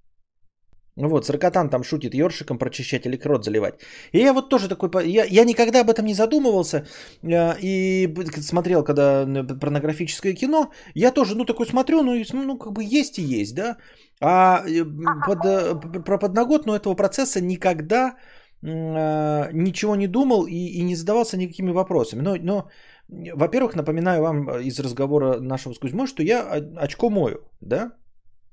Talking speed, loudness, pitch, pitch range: 150 wpm, -21 LUFS, 180 Hz, 145-220 Hz